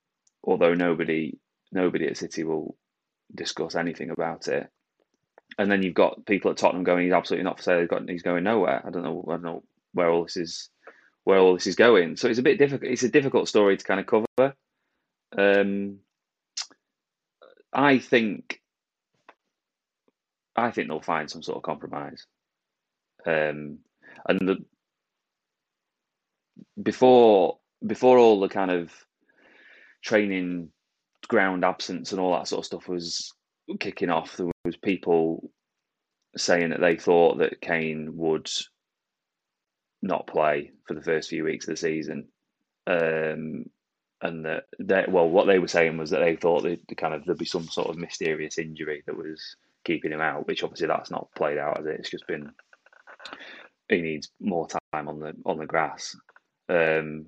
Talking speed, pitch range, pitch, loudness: 165 wpm, 80-100 Hz, 85 Hz, -25 LUFS